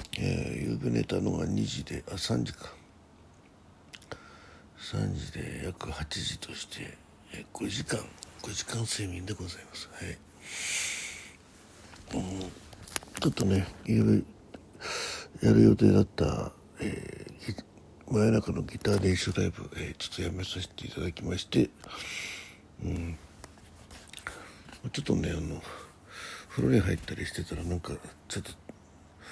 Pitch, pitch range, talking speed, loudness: 90 Hz, 85-100 Hz, 225 characters per minute, -31 LUFS